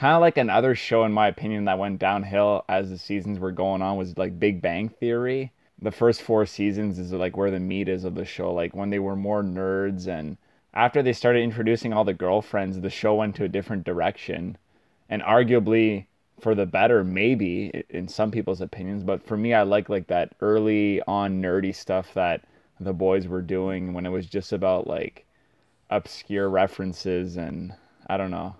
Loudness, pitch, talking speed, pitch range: -25 LUFS, 100 Hz, 195 wpm, 95-110 Hz